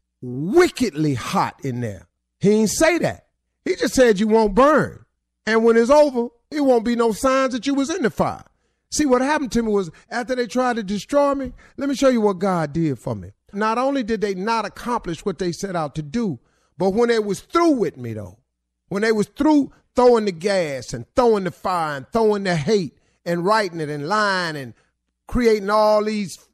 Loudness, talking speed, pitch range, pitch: -20 LUFS, 215 wpm, 165-245 Hz, 215 Hz